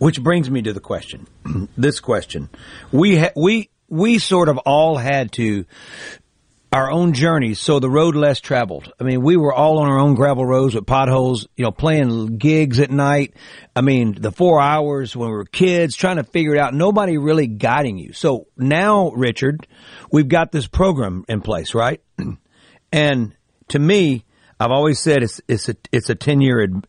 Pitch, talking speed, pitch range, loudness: 140 Hz, 190 wpm, 120-155 Hz, -17 LUFS